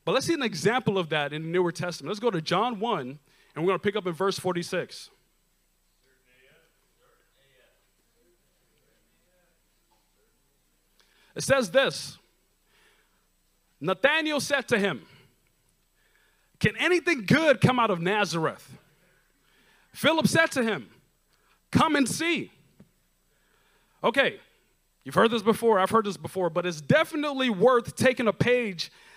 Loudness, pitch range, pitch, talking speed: -25 LUFS, 180-260 Hz, 215 Hz, 130 wpm